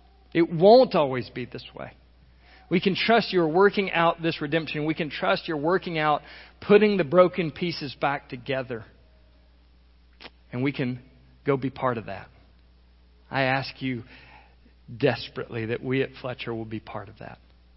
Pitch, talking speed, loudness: 130 Hz, 160 wpm, -24 LUFS